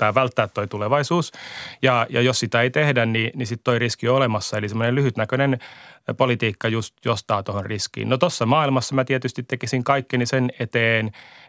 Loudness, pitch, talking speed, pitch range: -21 LUFS, 120 Hz, 185 wpm, 115-130 Hz